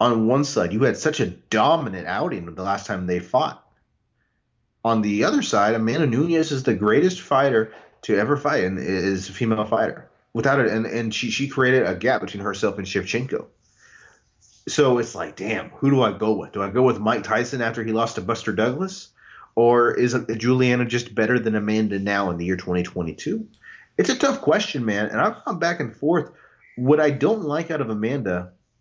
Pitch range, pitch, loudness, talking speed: 105-135 Hz, 115 Hz, -22 LUFS, 200 wpm